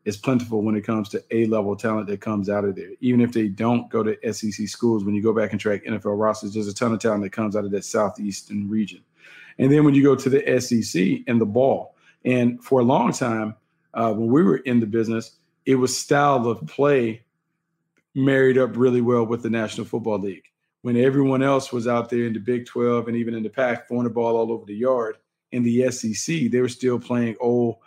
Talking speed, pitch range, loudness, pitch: 235 wpm, 110-125 Hz, -22 LUFS, 115 Hz